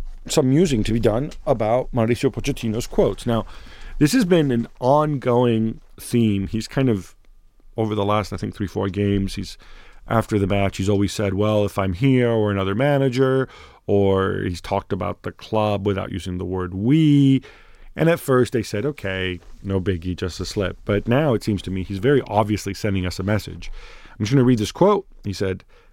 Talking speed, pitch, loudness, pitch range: 195 wpm, 105 Hz, -21 LUFS, 100-125 Hz